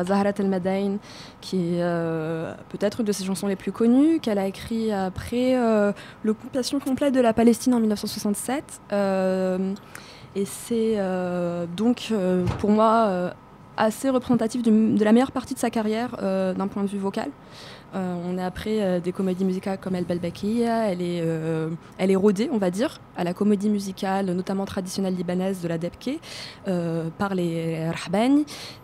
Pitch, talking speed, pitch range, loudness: 200 Hz, 175 wpm, 185-225 Hz, -24 LUFS